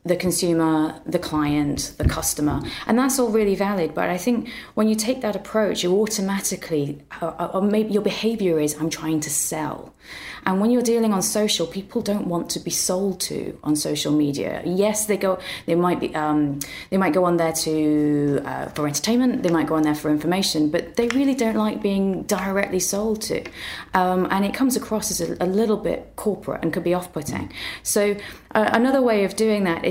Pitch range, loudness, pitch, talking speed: 160-215 Hz, -22 LUFS, 185 Hz, 205 wpm